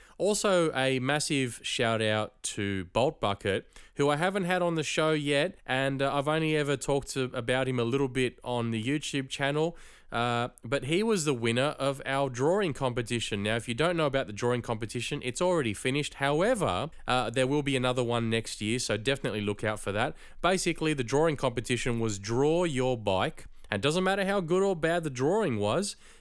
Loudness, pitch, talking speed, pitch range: -29 LUFS, 135 Hz, 200 wpm, 120-155 Hz